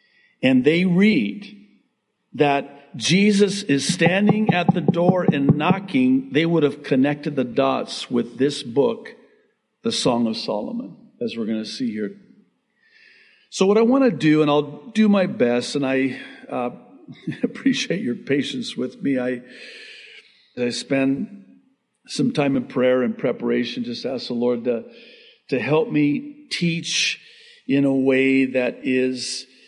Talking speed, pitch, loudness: 150 wpm, 170 Hz, -21 LUFS